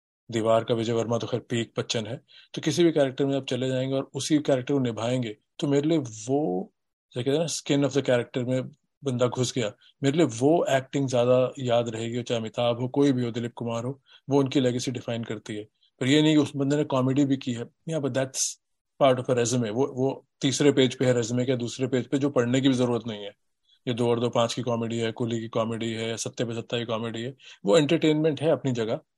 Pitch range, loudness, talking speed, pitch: 120-140 Hz, -26 LUFS, 245 wpm, 125 Hz